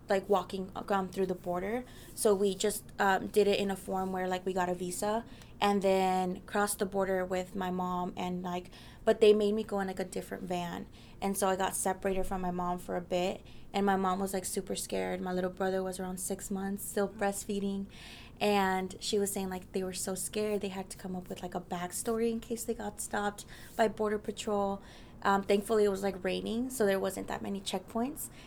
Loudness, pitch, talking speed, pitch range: -33 LUFS, 195 Hz, 225 wpm, 185-205 Hz